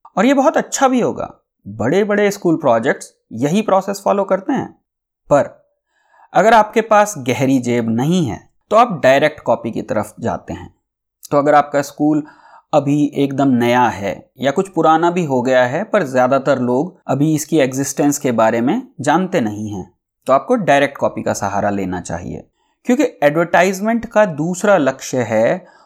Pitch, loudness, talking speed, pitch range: 150 Hz, -16 LUFS, 165 wpm, 130-205 Hz